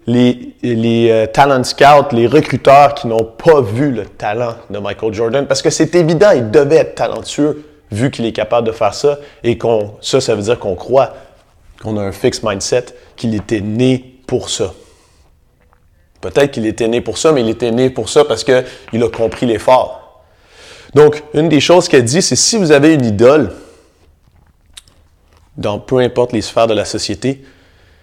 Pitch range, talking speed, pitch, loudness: 110-145 Hz, 185 wpm, 120 Hz, -13 LUFS